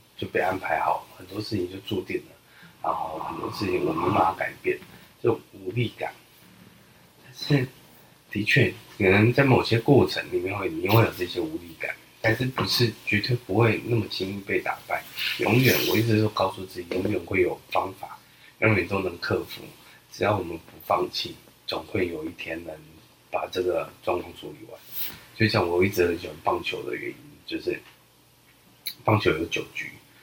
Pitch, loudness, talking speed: 115 Hz, -26 LUFS, 255 characters per minute